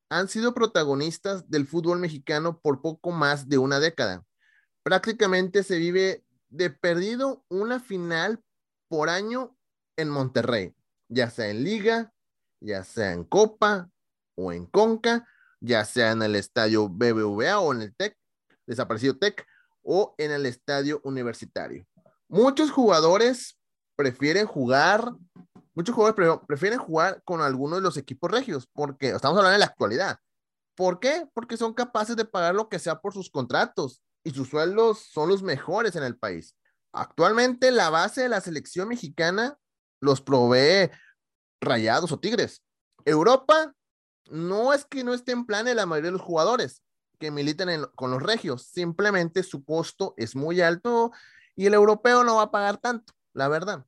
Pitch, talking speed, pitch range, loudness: 175 Hz, 155 wpm, 140-220 Hz, -24 LUFS